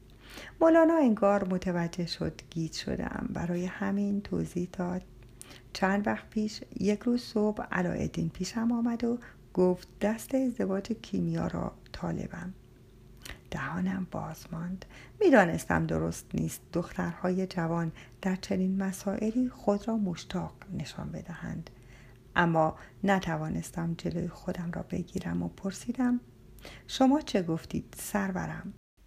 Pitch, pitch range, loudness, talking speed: 185 Hz, 160-210 Hz, -31 LUFS, 110 wpm